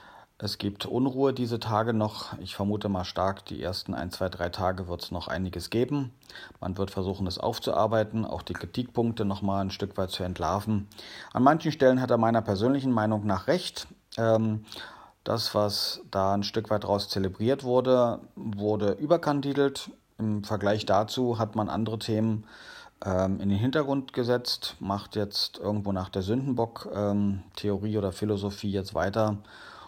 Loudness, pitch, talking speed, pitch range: -28 LUFS, 105 Hz, 165 wpm, 100-115 Hz